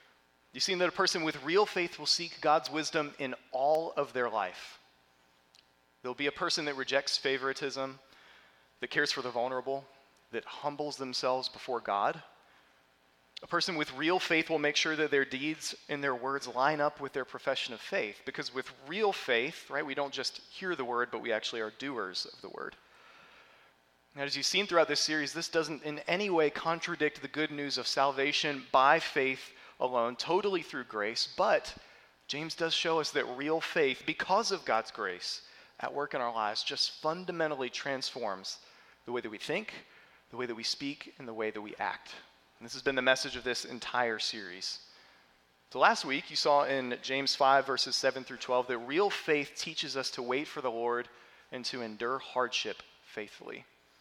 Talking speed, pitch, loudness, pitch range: 190 wpm, 135 Hz, -32 LUFS, 125-155 Hz